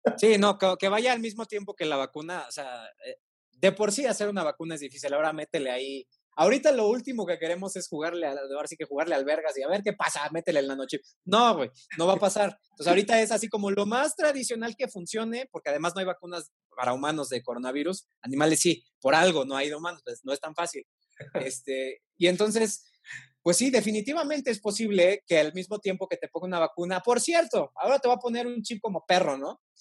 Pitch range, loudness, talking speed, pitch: 155-225 Hz, -27 LUFS, 225 wpm, 190 Hz